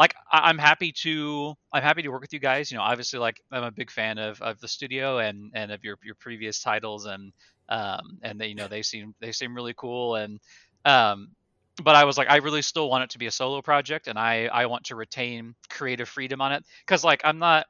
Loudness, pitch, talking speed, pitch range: -24 LUFS, 120 Hz, 245 wpm, 110-145 Hz